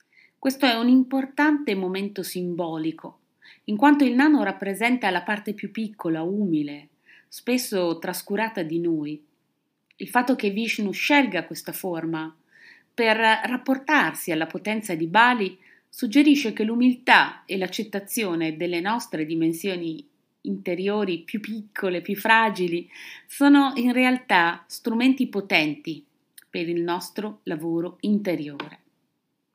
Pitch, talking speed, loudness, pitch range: 200 Hz, 115 wpm, -23 LUFS, 170-245 Hz